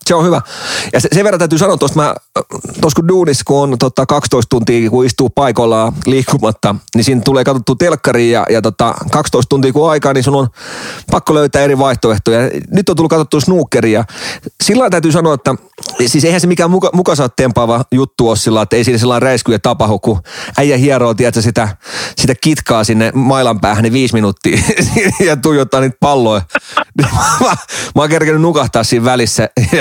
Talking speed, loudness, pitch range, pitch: 175 wpm, -11 LUFS, 120-155 Hz, 130 Hz